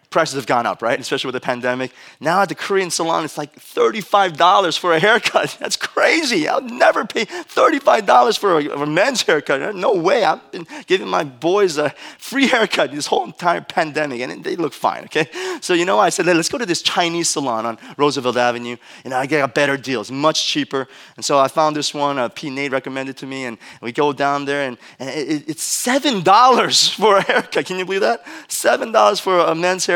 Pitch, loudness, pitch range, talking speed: 155 Hz, -17 LUFS, 135-195 Hz, 220 wpm